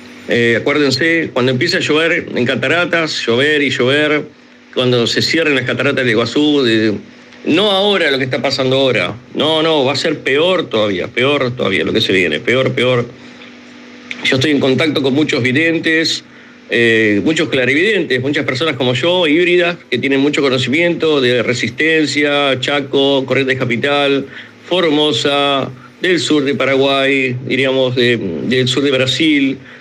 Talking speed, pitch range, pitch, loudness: 155 wpm, 125-150 Hz, 135 Hz, -13 LUFS